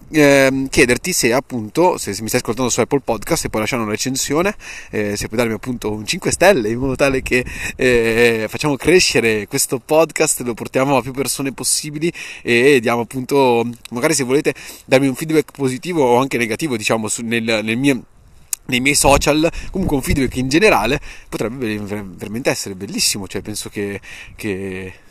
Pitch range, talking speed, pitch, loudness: 110-140 Hz, 180 wpm, 125 Hz, -17 LUFS